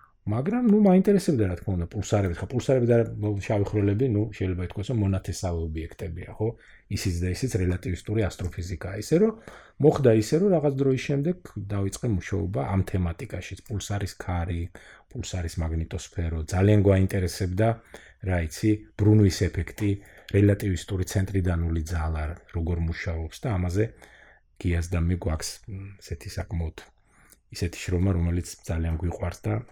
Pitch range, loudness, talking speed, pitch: 90-110 Hz, -26 LUFS, 130 wpm, 100 Hz